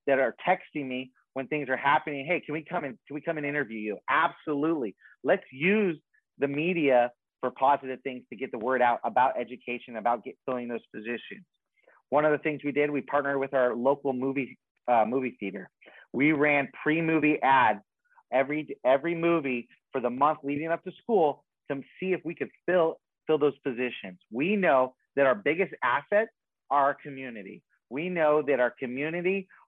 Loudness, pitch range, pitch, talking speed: -28 LUFS, 130-155 Hz, 140 Hz, 185 wpm